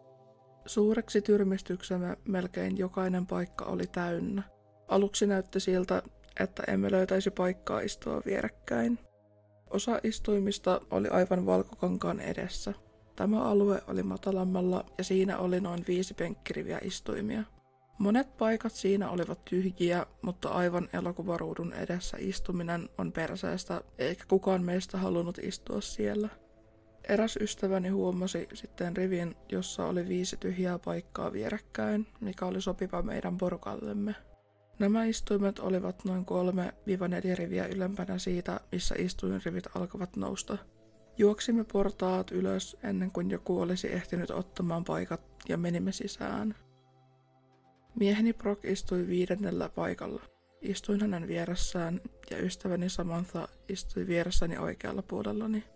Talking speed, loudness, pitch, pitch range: 115 wpm, -33 LUFS, 185 Hz, 170-195 Hz